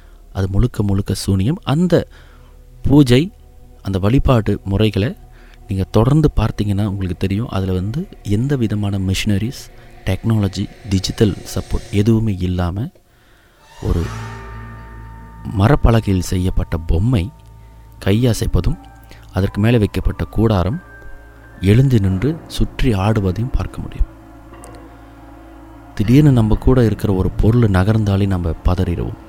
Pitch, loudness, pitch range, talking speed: 105 Hz, -17 LUFS, 95-120 Hz, 100 wpm